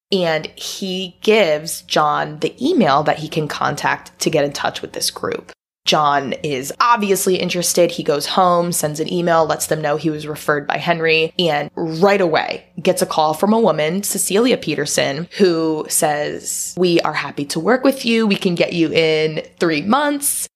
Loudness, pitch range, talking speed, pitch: -17 LUFS, 155-195 Hz, 180 wpm, 170 Hz